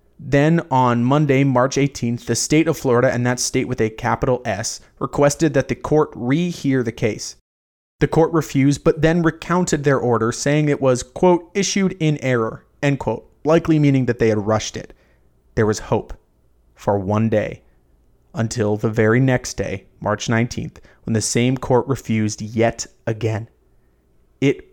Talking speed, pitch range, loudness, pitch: 165 wpm, 110-145 Hz, -19 LUFS, 125 Hz